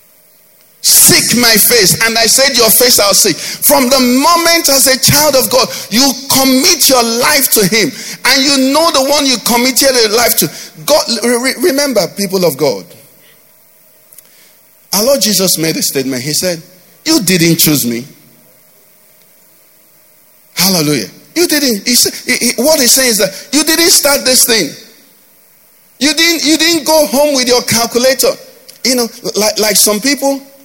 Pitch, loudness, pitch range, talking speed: 250 Hz, -8 LUFS, 210-280 Hz, 160 wpm